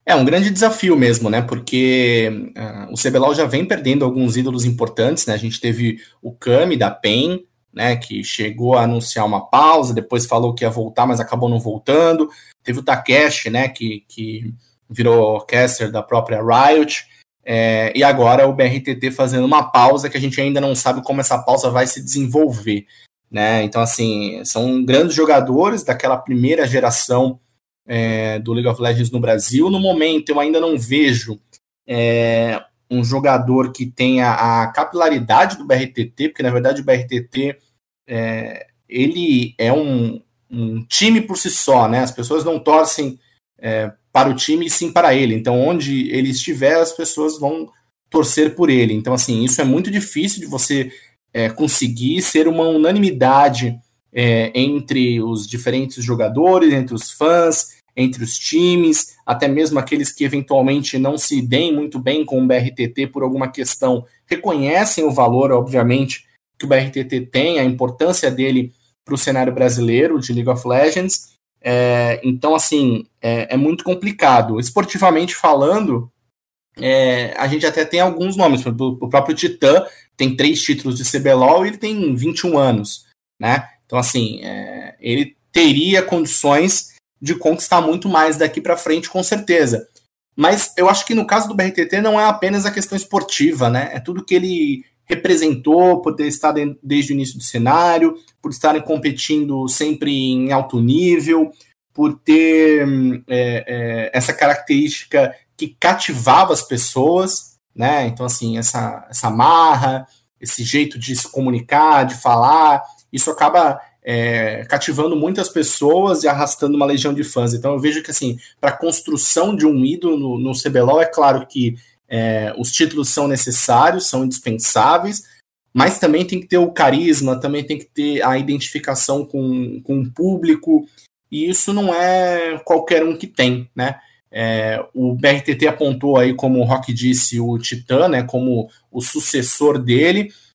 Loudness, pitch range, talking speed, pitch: -15 LUFS, 120-155 Hz, 160 wpm, 135 Hz